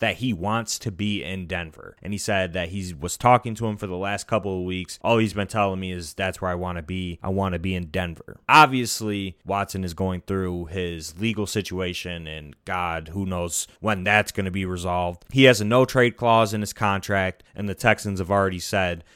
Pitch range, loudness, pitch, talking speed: 90-105 Hz, -24 LUFS, 95 Hz, 230 wpm